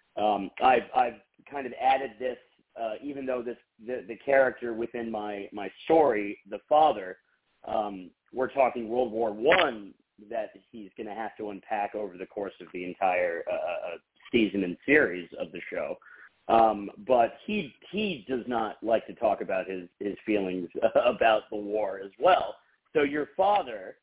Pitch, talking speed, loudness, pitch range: 115 Hz, 165 wpm, -28 LUFS, 100-130 Hz